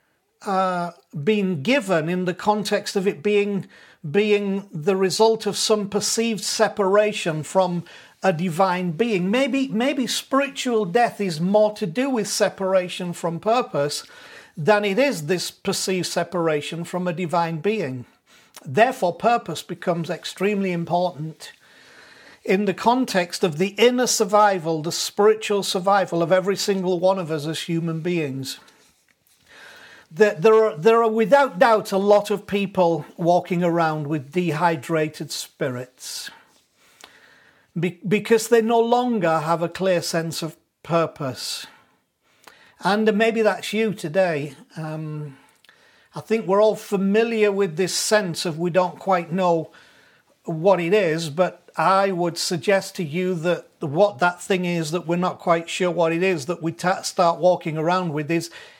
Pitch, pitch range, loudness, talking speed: 190 Hz, 170-210 Hz, -21 LUFS, 145 wpm